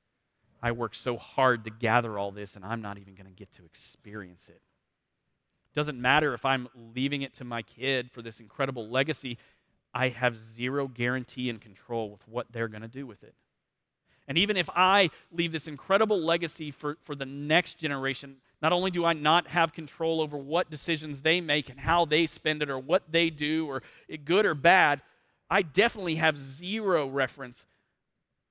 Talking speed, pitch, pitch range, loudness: 185 wpm, 135 Hz, 120-160 Hz, -28 LUFS